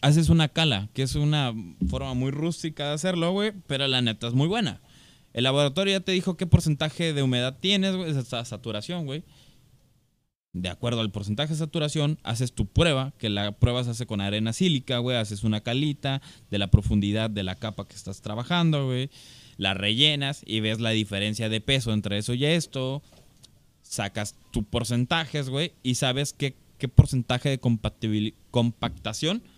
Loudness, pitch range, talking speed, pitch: -26 LUFS, 110-150 Hz, 175 wpm, 130 Hz